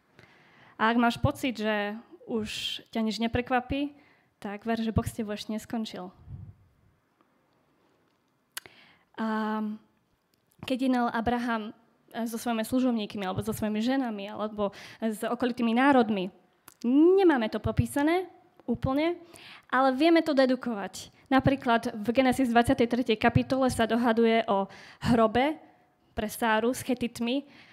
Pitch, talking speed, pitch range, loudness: 235 Hz, 110 wpm, 220-260 Hz, -27 LUFS